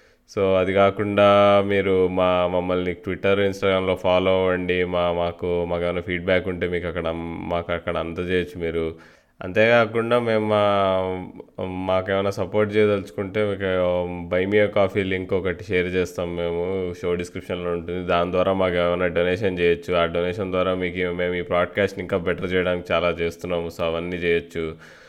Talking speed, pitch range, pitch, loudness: 145 wpm, 85-95 Hz, 90 Hz, -22 LUFS